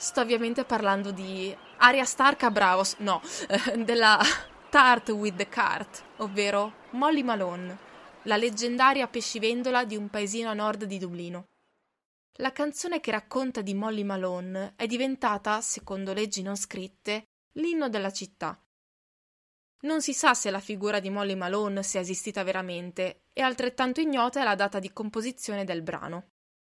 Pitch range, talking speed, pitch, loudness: 195-245 Hz, 145 wpm, 210 Hz, -27 LUFS